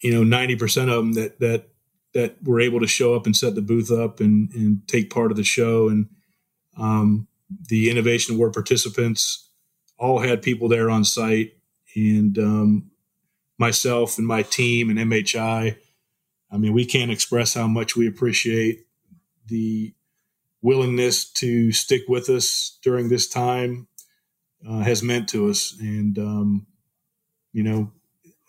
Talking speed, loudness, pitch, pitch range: 155 wpm, -21 LUFS, 115 Hz, 110-125 Hz